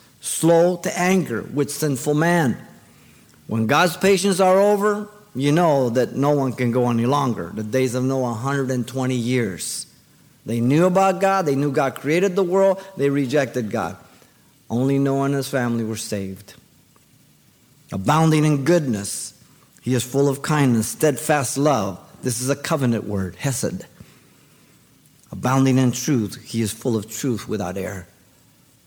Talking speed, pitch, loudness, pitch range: 150 wpm, 135 Hz, -20 LUFS, 120-150 Hz